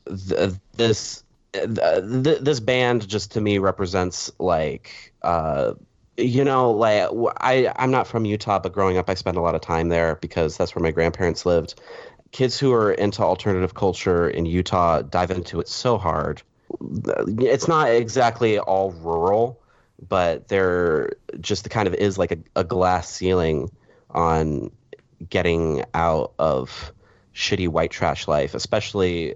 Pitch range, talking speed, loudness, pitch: 85-115 Hz, 145 wpm, -22 LUFS, 95 Hz